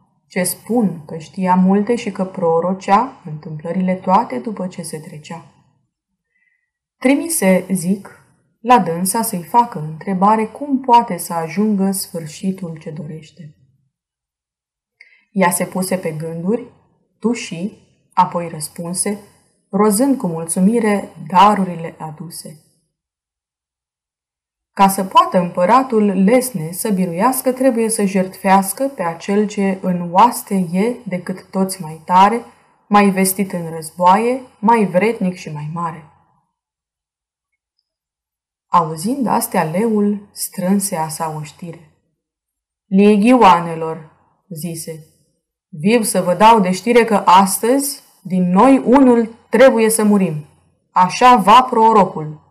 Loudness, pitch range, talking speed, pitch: -15 LUFS, 165-215 Hz, 110 wpm, 185 Hz